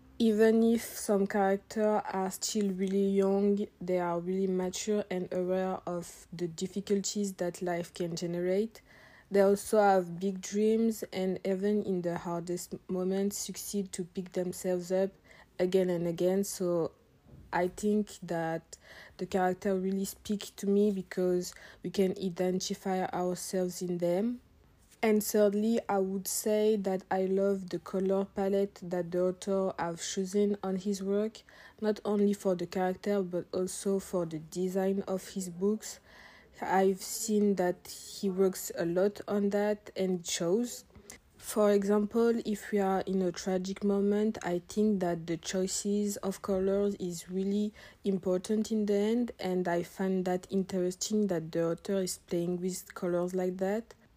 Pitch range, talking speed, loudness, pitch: 180-205 Hz, 150 wpm, -31 LUFS, 190 Hz